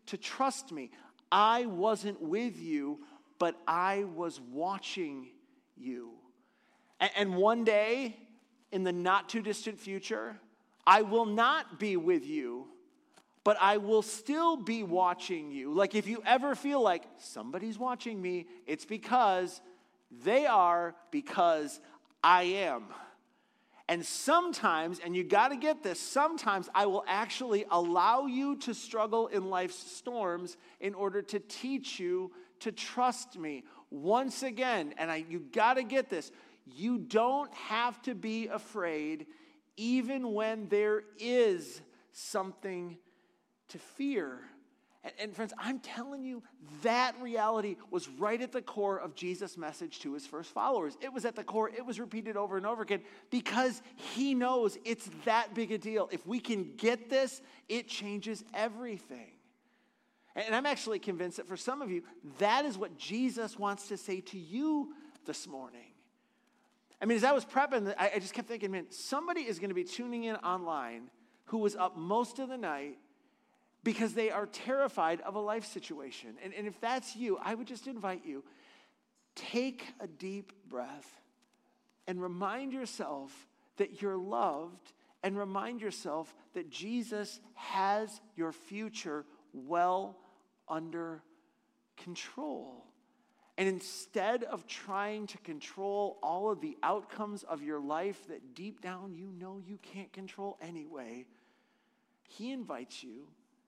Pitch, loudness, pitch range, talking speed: 215 Hz, -34 LUFS, 190-255 Hz, 145 wpm